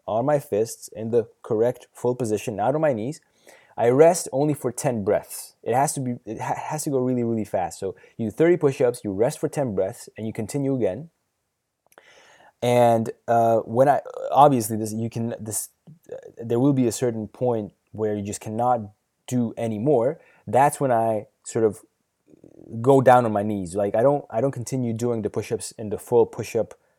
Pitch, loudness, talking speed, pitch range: 120 Hz, -23 LUFS, 200 wpm, 110-140 Hz